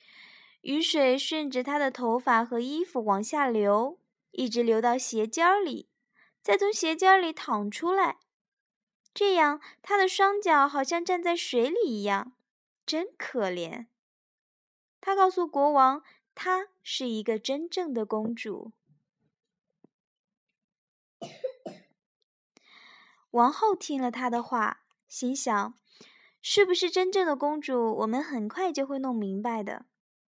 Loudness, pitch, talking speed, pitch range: -27 LUFS, 270 Hz, 175 characters per minute, 230-350 Hz